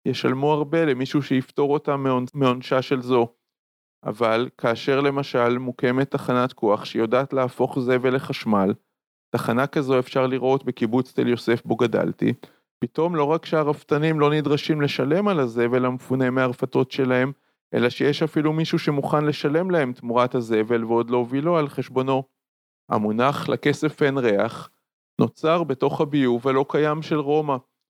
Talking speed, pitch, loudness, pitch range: 135 wpm, 135 Hz, -22 LUFS, 125-150 Hz